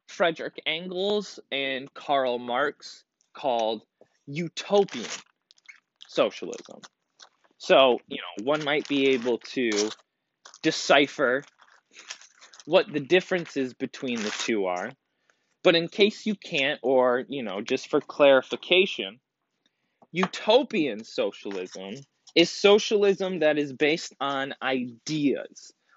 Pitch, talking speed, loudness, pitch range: 145 Hz, 100 wpm, -25 LUFS, 130-170 Hz